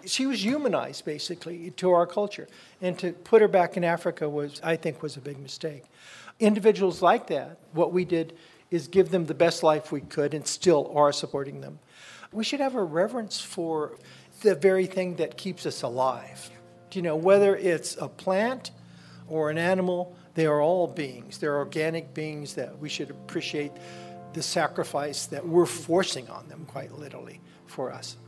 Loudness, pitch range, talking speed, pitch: -27 LUFS, 150-185 Hz, 180 wpm, 170 Hz